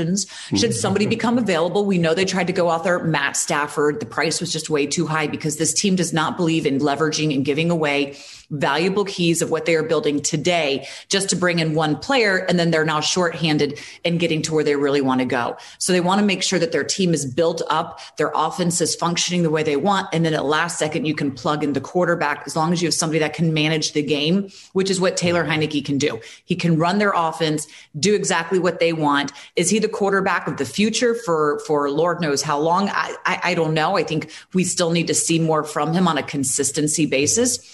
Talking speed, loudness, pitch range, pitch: 240 wpm, -20 LUFS, 150-180 Hz, 160 Hz